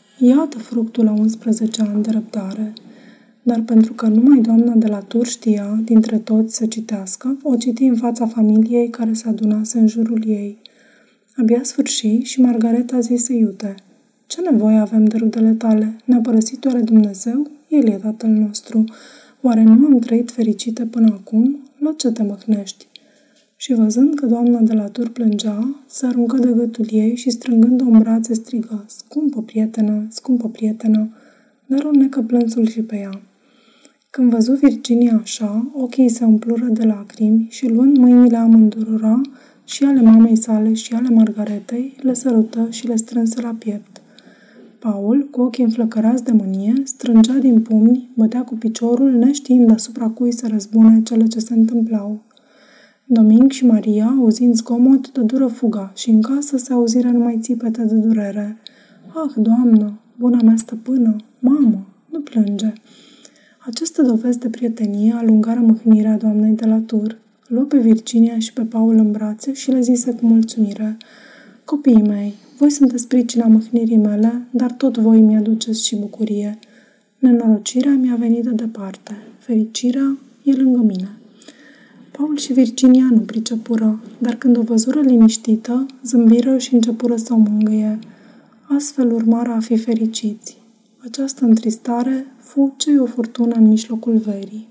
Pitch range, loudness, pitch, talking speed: 220-250 Hz, -15 LUFS, 230 Hz, 150 wpm